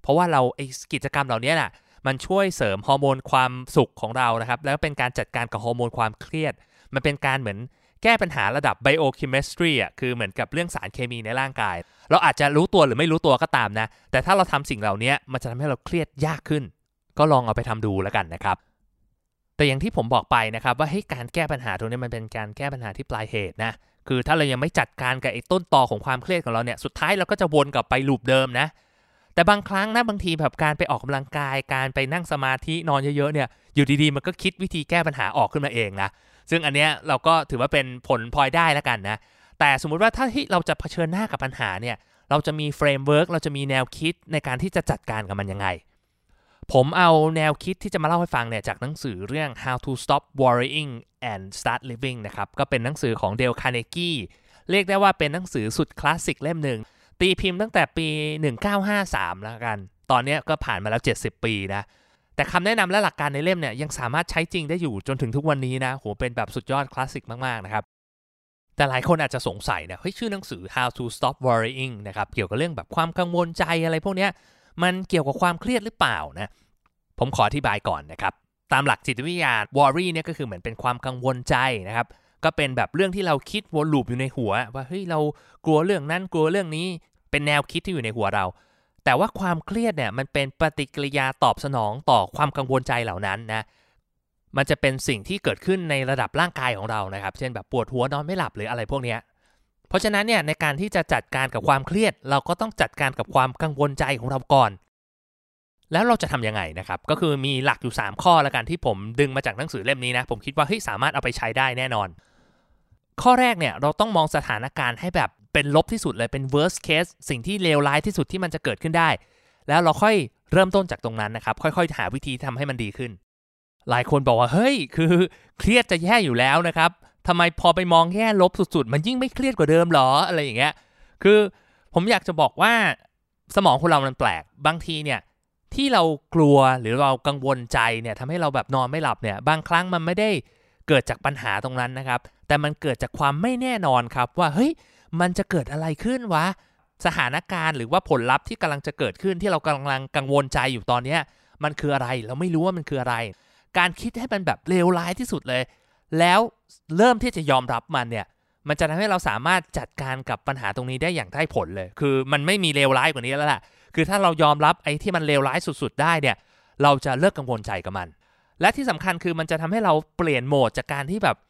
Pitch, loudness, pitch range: 145 Hz, -23 LUFS, 125-170 Hz